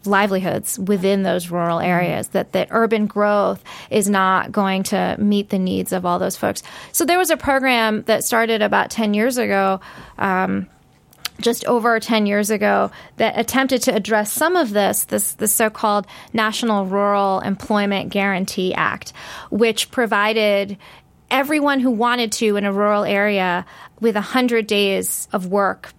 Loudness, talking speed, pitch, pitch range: -18 LUFS, 155 wpm, 205 Hz, 195-230 Hz